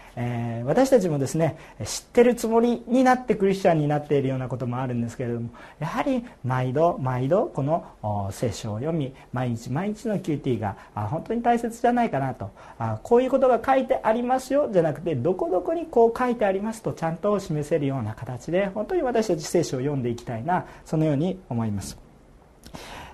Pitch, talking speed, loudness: 160 Hz, 395 characters per minute, -24 LUFS